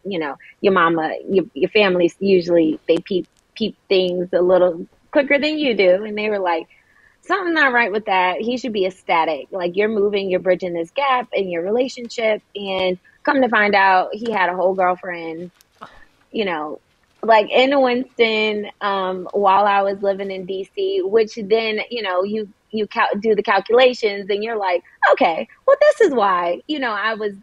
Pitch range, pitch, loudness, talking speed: 185-235 Hz, 200 Hz, -18 LUFS, 185 wpm